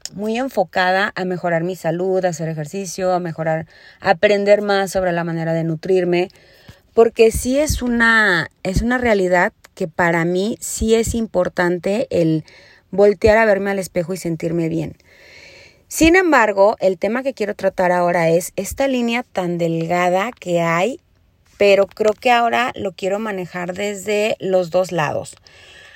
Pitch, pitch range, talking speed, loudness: 190 Hz, 175-210 Hz, 155 wpm, -18 LUFS